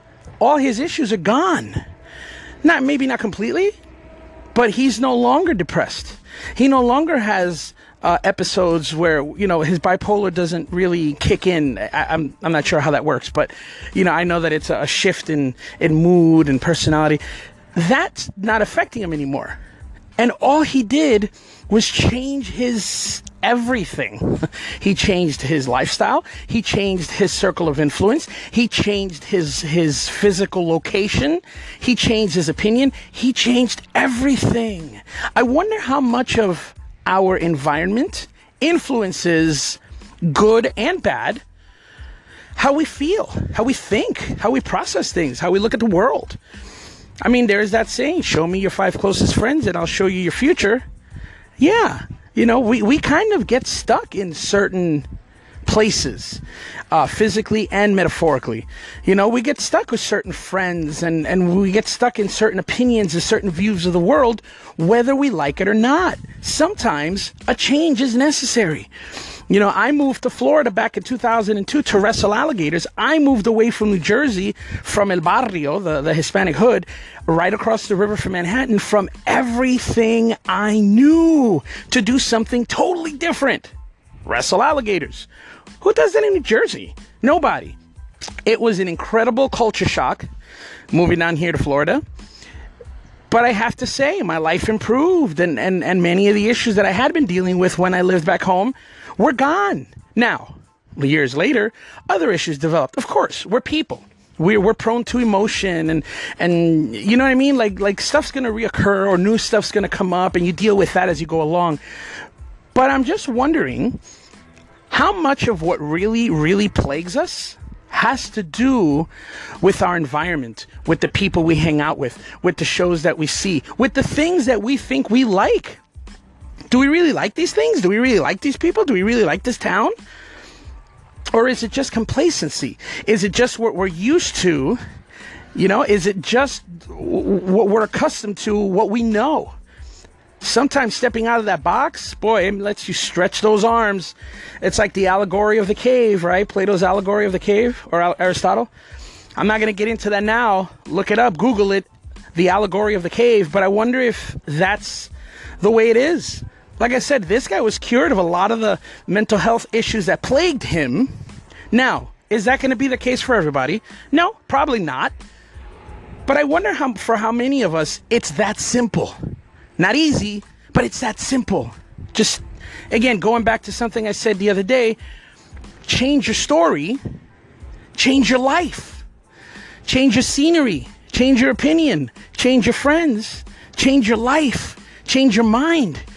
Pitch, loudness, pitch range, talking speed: 215 Hz, -17 LUFS, 180-255 Hz, 170 wpm